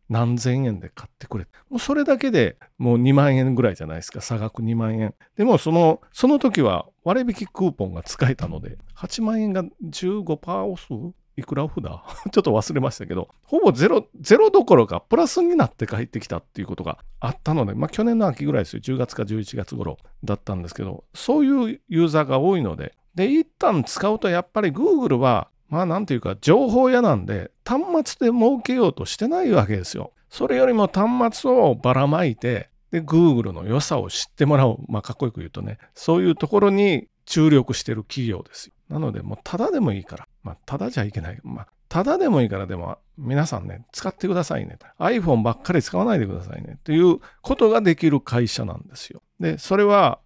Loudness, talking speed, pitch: -21 LUFS, 405 characters per minute, 160 Hz